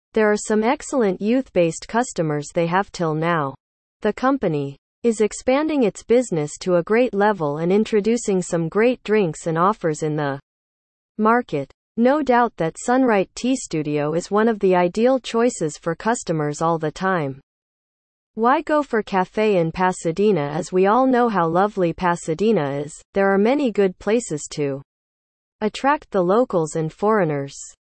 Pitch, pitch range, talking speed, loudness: 190 Hz, 160-225 Hz, 155 wpm, -20 LUFS